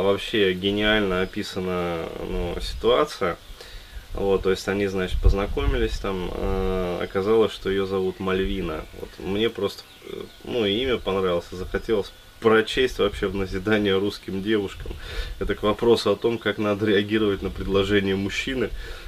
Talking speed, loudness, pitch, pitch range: 130 wpm, -24 LUFS, 95 Hz, 95-105 Hz